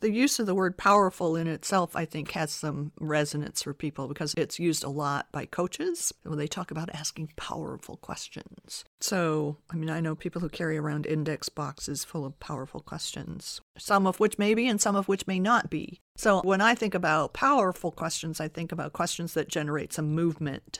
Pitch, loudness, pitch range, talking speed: 165 Hz, -29 LUFS, 150-190 Hz, 210 wpm